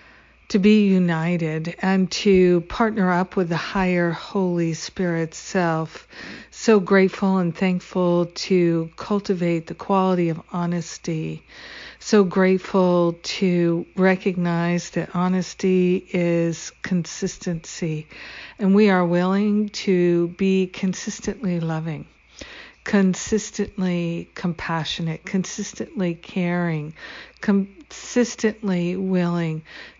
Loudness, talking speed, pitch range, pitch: -22 LUFS, 90 wpm, 170-195 Hz, 180 Hz